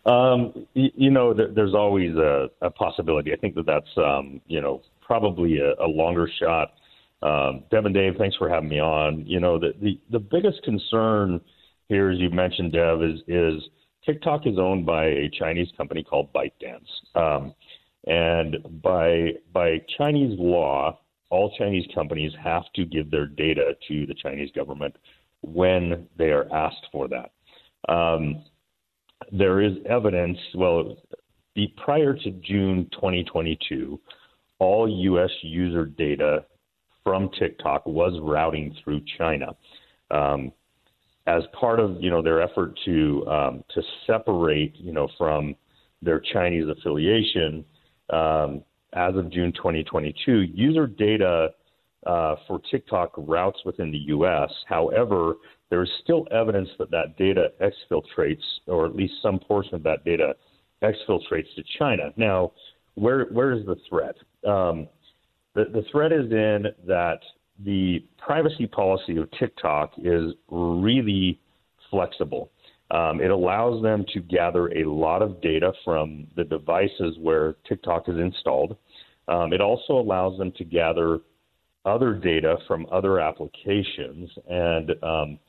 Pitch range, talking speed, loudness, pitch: 80-105 Hz, 145 wpm, -24 LUFS, 90 Hz